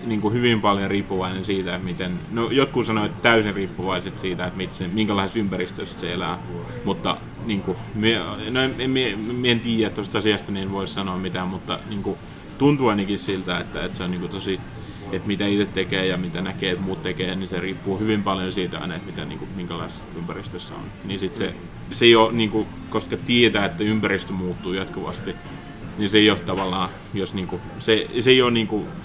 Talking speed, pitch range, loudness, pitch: 205 wpm, 95-110 Hz, -23 LUFS, 100 Hz